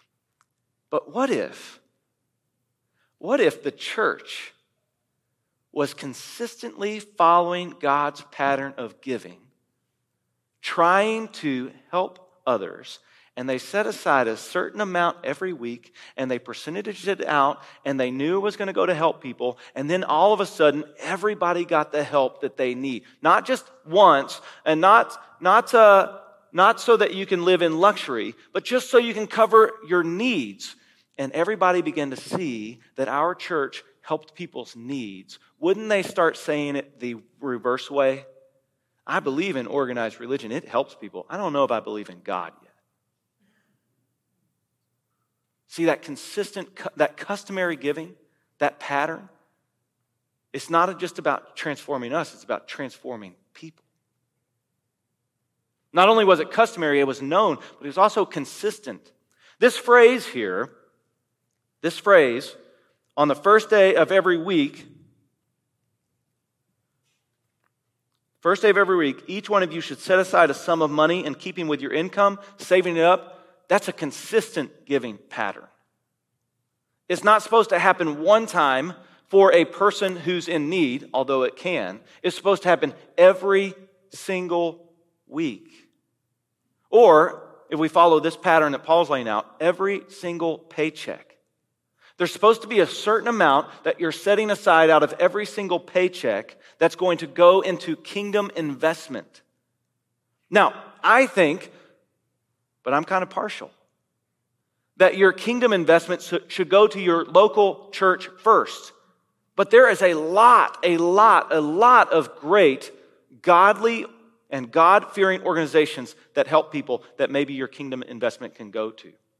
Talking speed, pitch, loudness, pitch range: 145 wpm, 175 Hz, -21 LUFS, 140-200 Hz